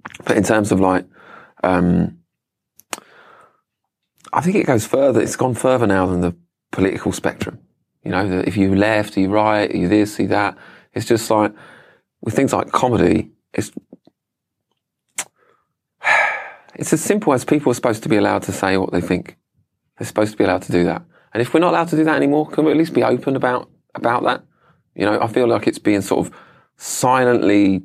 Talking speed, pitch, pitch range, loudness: 195 wpm, 105 Hz, 95-125 Hz, -18 LUFS